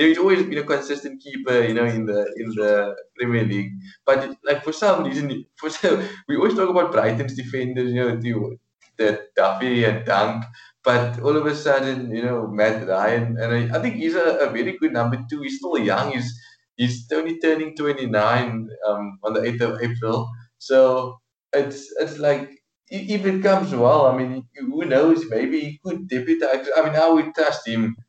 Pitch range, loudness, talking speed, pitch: 115-150 Hz, -21 LUFS, 190 wpm, 130 Hz